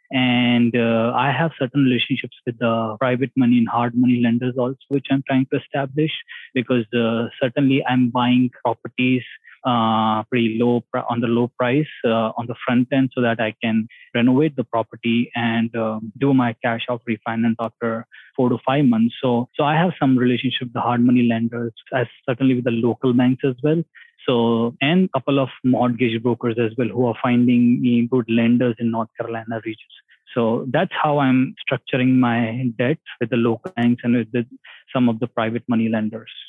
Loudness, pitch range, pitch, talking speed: -20 LUFS, 115-130 Hz, 120 Hz, 190 wpm